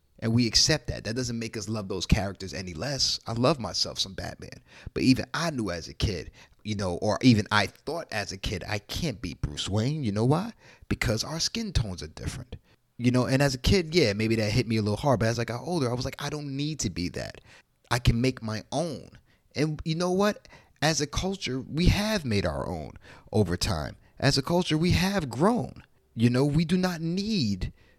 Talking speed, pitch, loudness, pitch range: 230 wpm, 120 Hz, -27 LUFS, 105-150 Hz